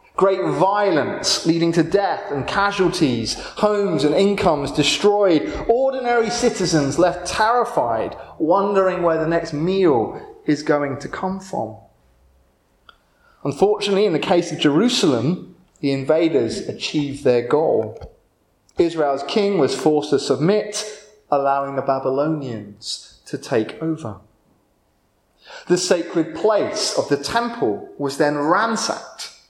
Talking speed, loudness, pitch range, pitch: 115 wpm, -19 LUFS, 145-205 Hz, 170 Hz